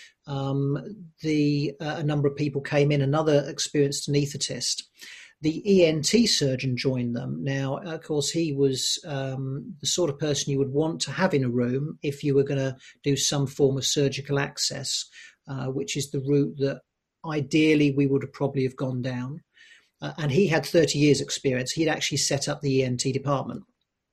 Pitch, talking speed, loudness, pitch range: 140 Hz, 185 wpm, -25 LUFS, 135-150 Hz